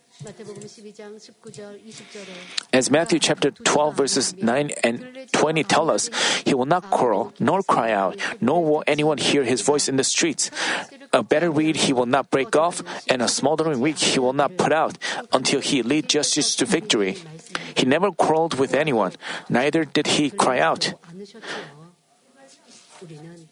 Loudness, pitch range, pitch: -21 LUFS, 145-205 Hz, 155 Hz